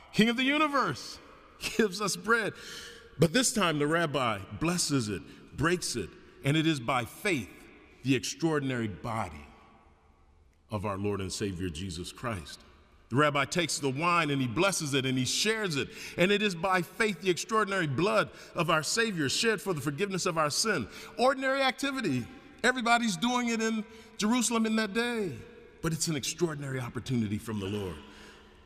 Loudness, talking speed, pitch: -29 LUFS, 170 wpm, 165 Hz